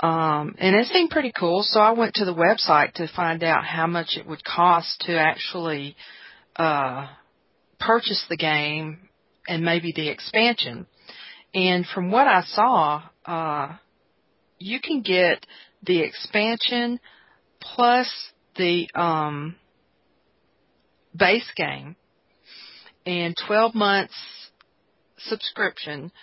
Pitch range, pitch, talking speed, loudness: 160-215 Hz, 175 Hz, 115 wpm, -22 LUFS